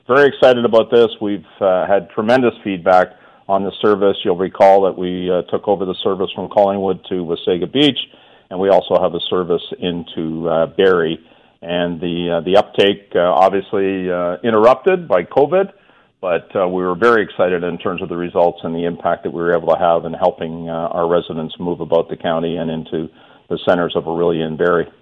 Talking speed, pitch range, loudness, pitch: 200 wpm, 85-100 Hz, -16 LUFS, 90 Hz